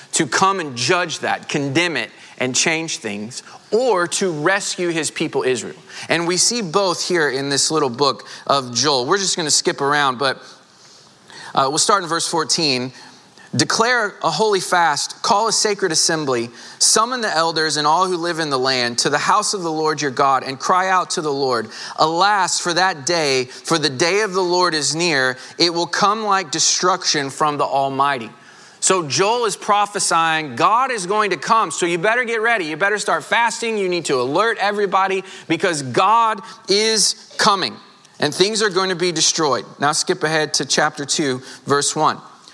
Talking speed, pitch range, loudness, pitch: 190 wpm, 145-195 Hz, -17 LUFS, 170 Hz